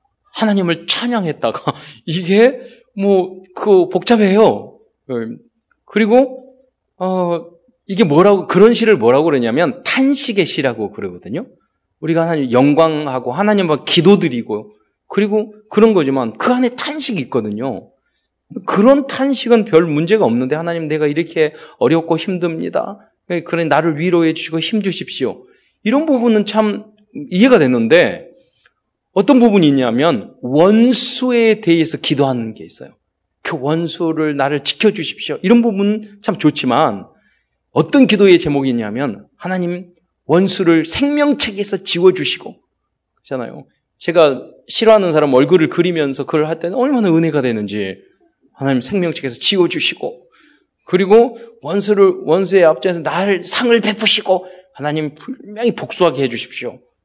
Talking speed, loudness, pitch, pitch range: 305 characters per minute, -14 LUFS, 185 Hz, 155-225 Hz